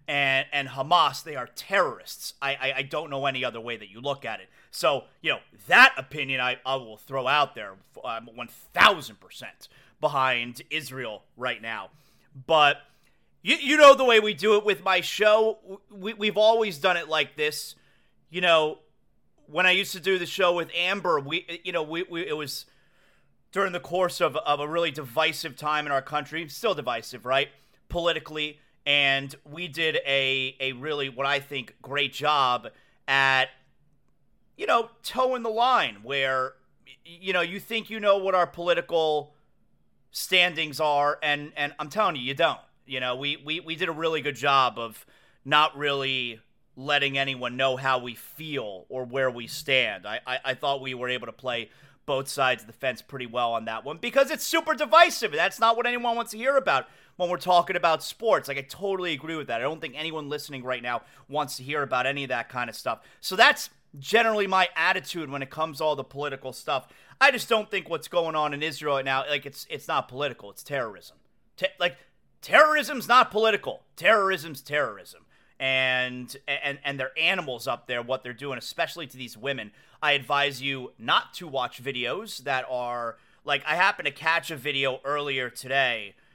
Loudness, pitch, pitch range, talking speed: -25 LUFS, 145 Hz, 135-175 Hz, 190 wpm